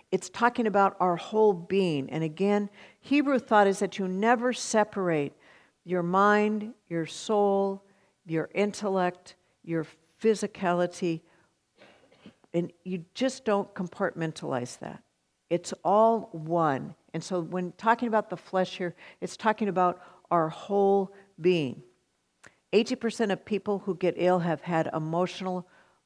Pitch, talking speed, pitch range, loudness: 185 Hz, 125 wpm, 170-205 Hz, -28 LUFS